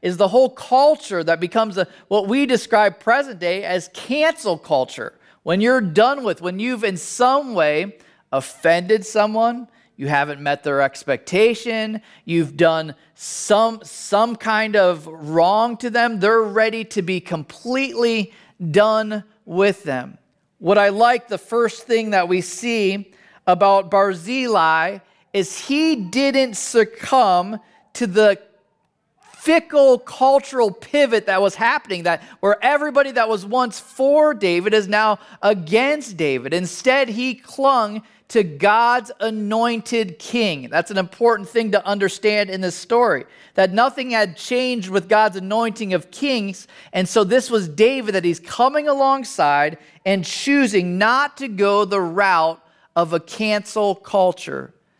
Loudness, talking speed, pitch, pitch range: -18 LUFS, 140 wpm, 215 Hz, 185-235 Hz